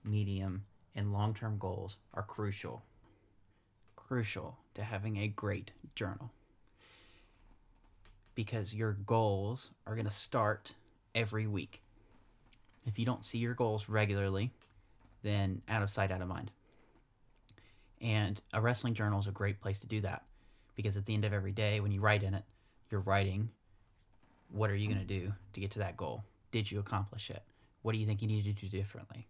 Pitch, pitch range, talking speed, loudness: 105 Hz, 100-110 Hz, 170 wpm, -37 LUFS